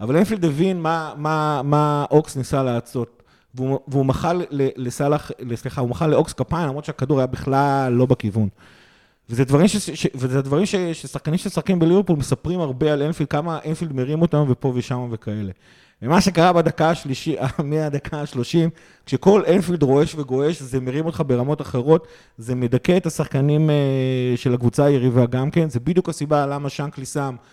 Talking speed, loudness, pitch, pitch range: 155 wpm, -20 LUFS, 145 Hz, 130-160 Hz